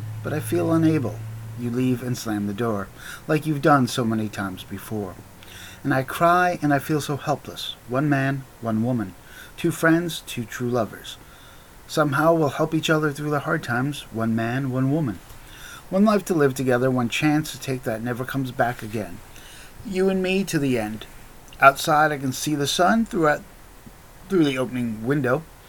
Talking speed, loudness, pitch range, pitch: 180 wpm, -23 LUFS, 115-155 Hz, 135 Hz